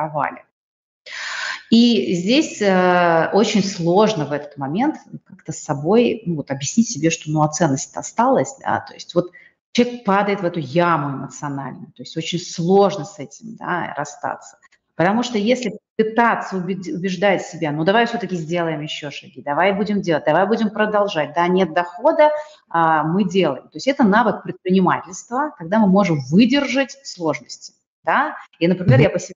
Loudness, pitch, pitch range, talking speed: -19 LUFS, 185 Hz, 160-215 Hz, 165 wpm